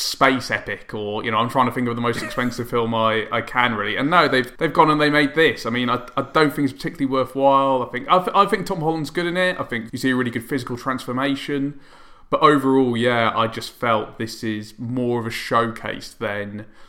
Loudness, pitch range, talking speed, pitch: -20 LUFS, 115-140 Hz, 245 wpm, 125 Hz